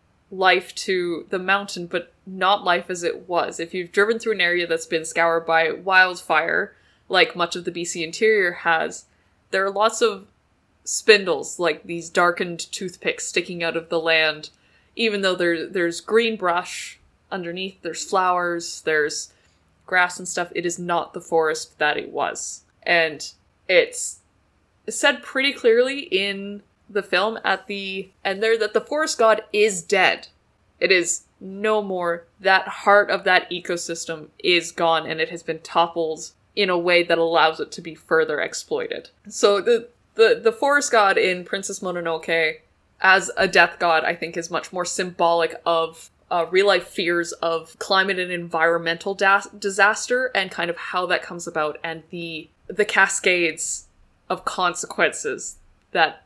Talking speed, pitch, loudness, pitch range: 160 wpm, 180 Hz, -21 LUFS, 165-200 Hz